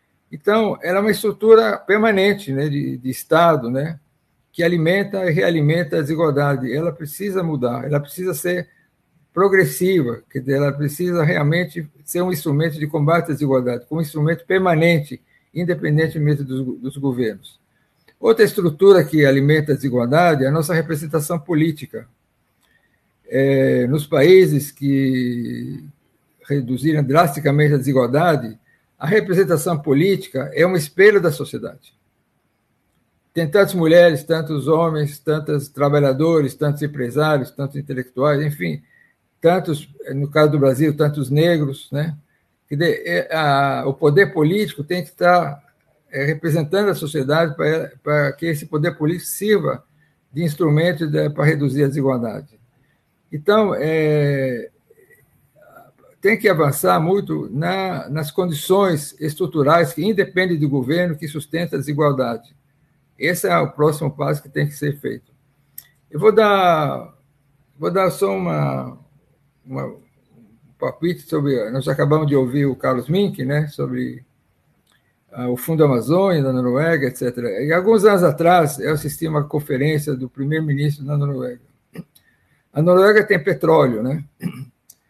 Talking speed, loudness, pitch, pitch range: 130 wpm, -18 LUFS, 150 Hz, 140-170 Hz